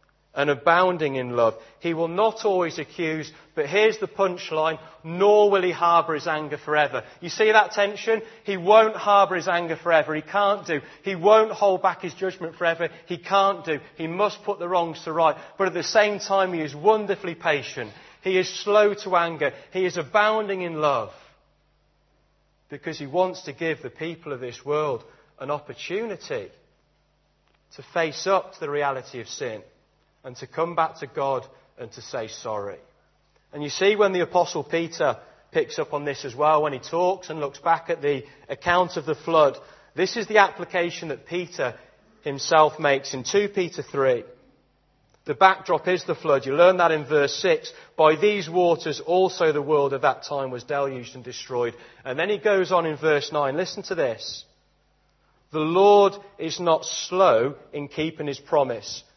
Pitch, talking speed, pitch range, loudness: 170 Hz, 185 wpm, 150-195 Hz, -23 LUFS